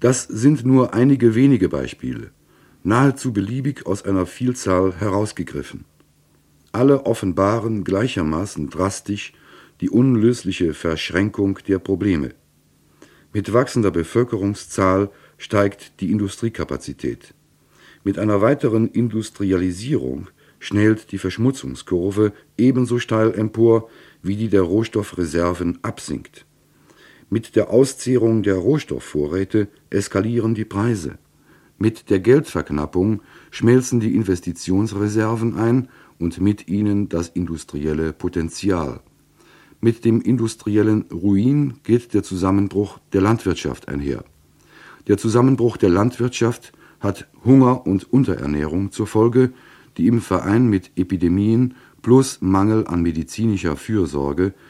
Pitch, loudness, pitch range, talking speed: 100 Hz, -19 LUFS, 90-115 Hz, 100 wpm